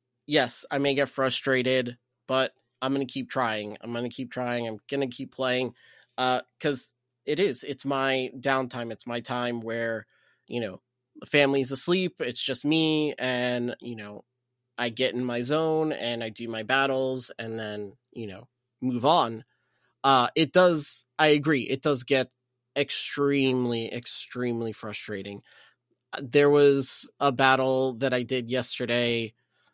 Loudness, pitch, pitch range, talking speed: -26 LUFS, 125 Hz, 120-135 Hz, 155 wpm